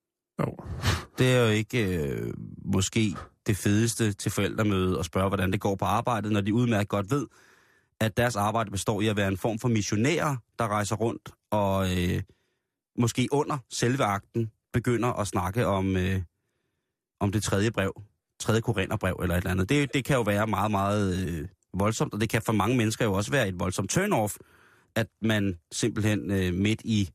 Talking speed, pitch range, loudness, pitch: 185 wpm, 95-115 Hz, -27 LUFS, 105 Hz